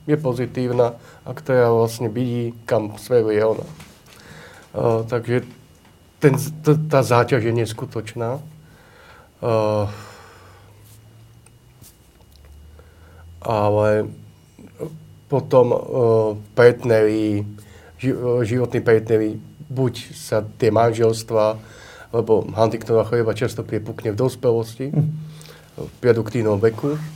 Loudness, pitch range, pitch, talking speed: -20 LUFS, 110-125 Hz, 115 Hz, 80 wpm